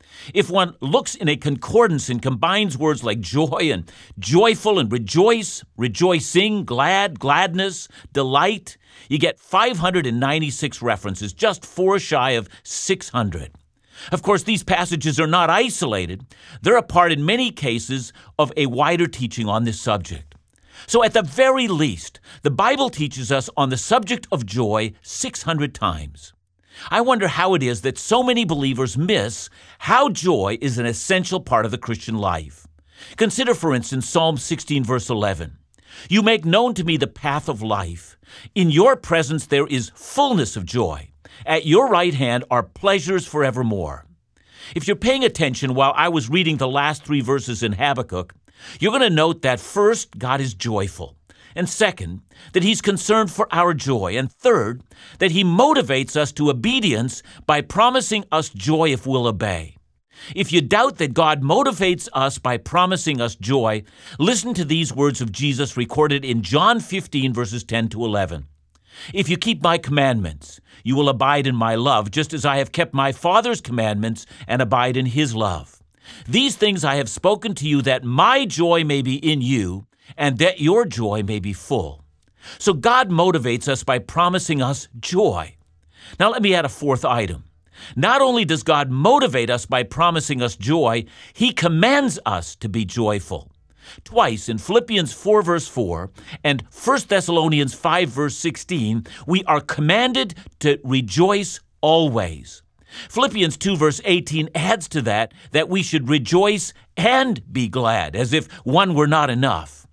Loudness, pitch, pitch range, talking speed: -19 LUFS, 145 Hz, 115-180 Hz, 165 wpm